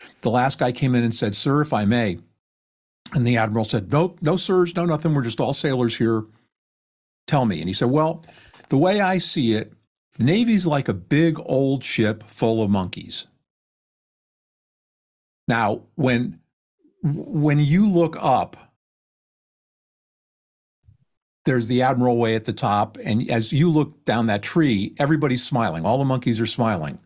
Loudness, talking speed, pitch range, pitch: -21 LUFS, 160 wpm, 110-155 Hz, 125 Hz